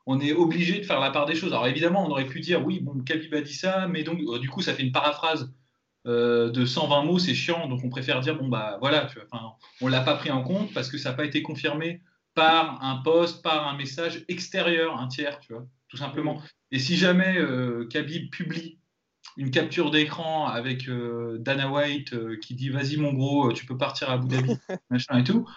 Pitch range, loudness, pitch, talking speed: 130-165 Hz, -26 LUFS, 145 Hz, 230 wpm